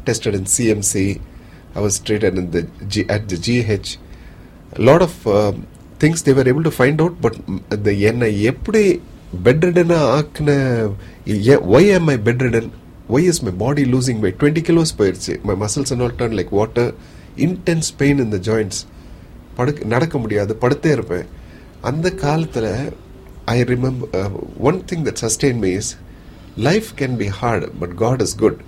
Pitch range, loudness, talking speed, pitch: 100-140 Hz, -17 LUFS, 145 wpm, 115 Hz